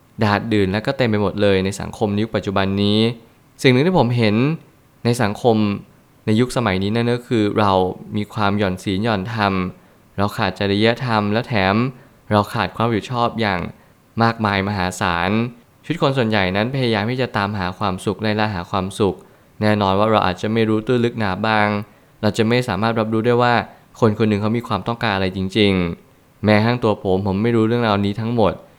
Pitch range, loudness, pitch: 100-120 Hz, -19 LUFS, 110 Hz